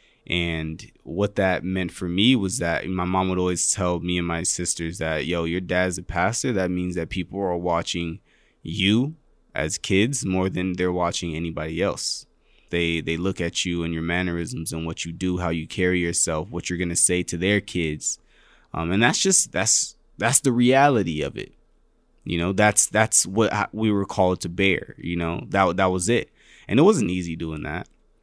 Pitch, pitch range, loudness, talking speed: 90 Hz, 85-95 Hz, -23 LUFS, 200 wpm